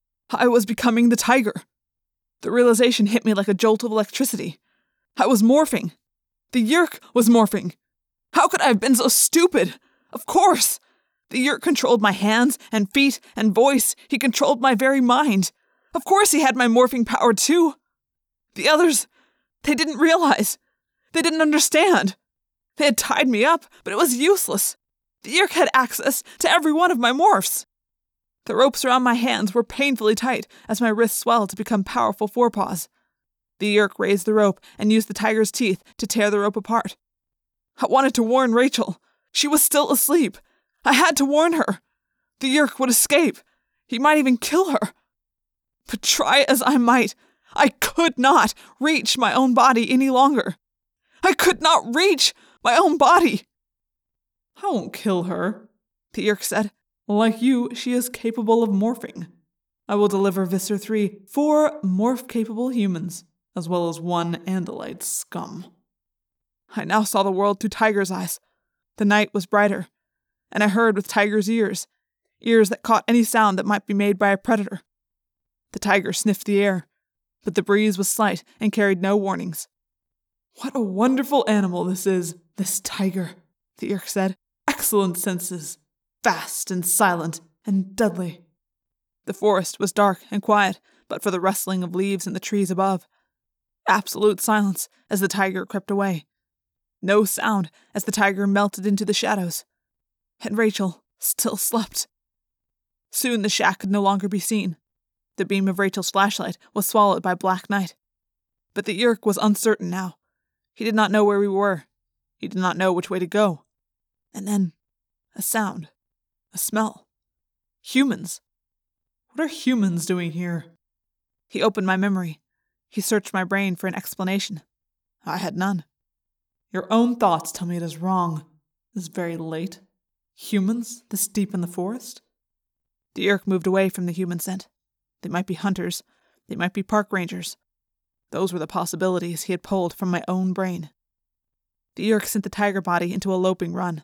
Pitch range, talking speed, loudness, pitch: 190-245 Hz, 165 wpm, -20 LUFS, 210 Hz